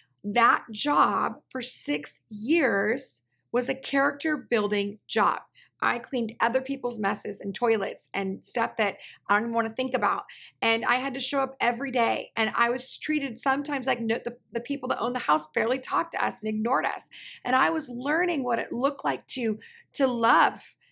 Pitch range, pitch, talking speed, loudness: 225-270 Hz, 240 Hz, 185 wpm, -27 LUFS